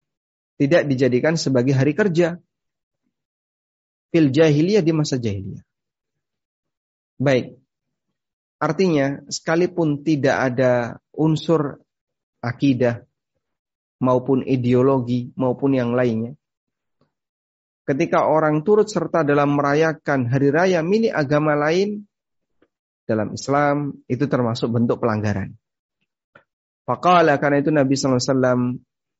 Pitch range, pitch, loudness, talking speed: 125-155 Hz, 140 Hz, -19 LUFS, 90 wpm